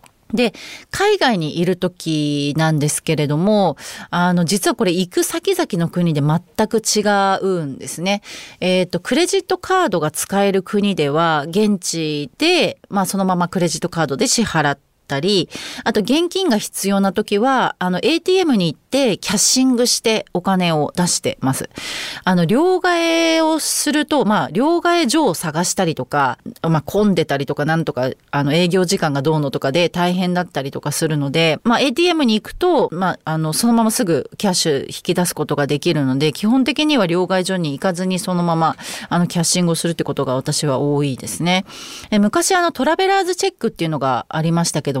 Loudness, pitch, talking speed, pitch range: -17 LUFS, 180 Hz, 370 characters per minute, 155-235 Hz